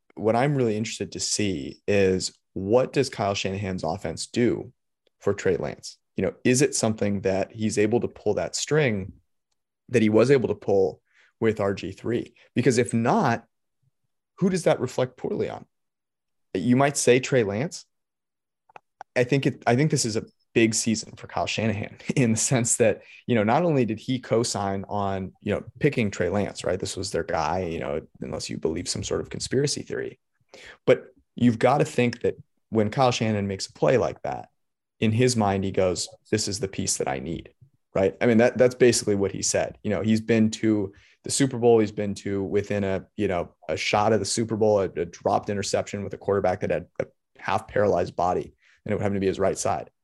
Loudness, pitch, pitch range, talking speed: -25 LUFS, 110 Hz, 100-125 Hz, 205 wpm